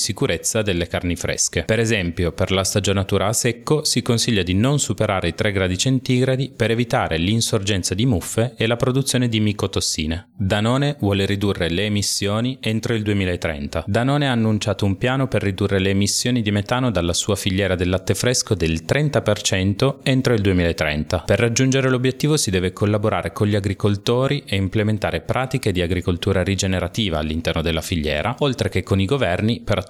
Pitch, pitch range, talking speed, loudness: 105 Hz, 95-120 Hz, 170 wpm, -20 LUFS